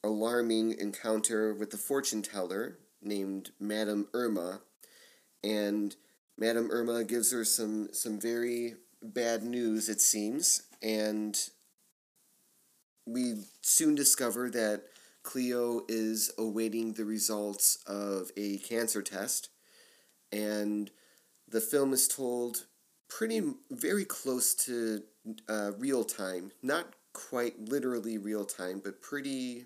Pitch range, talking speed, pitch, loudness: 105-120 Hz, 110 wpm, 110 Hz, -32 LUFS